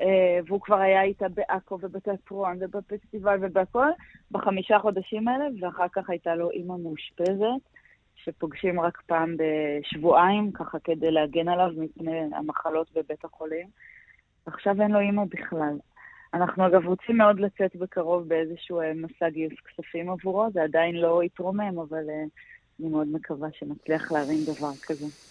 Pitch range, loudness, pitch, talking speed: 160-195 Hz, -26 LUFS, 175 Hz, 135 wpm